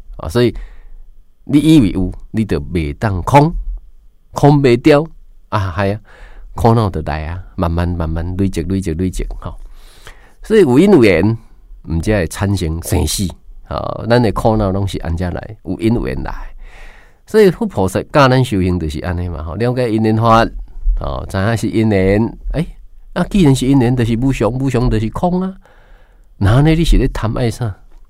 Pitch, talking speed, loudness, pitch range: 105 Hz, 245 characters per minute, -15 LUFS, 90-125 Hz